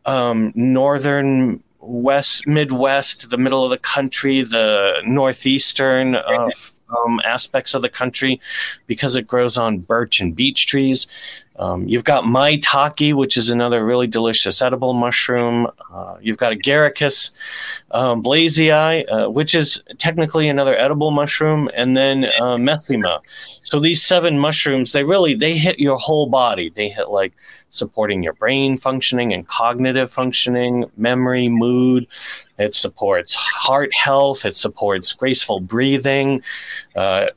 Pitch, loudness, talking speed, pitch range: 130 Hz, -16 LUFS, 135 wpm, 120-145 Hz